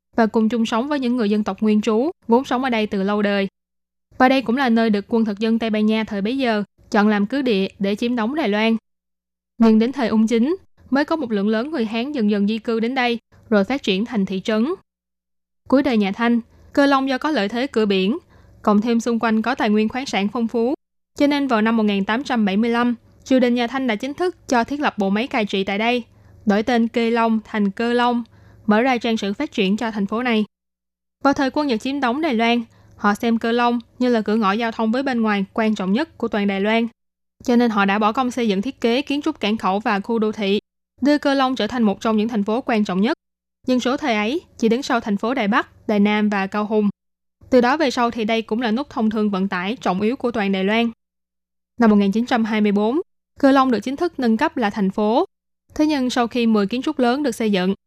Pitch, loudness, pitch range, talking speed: 225 Hz, -20 LUFS, 205-245 Hz, 255 wpm